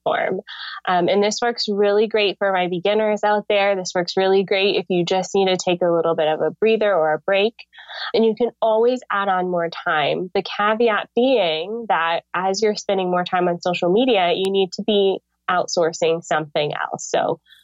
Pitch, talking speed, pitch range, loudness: 195 Hz, 195 wpm, 180-210 Hz, -20 LUFS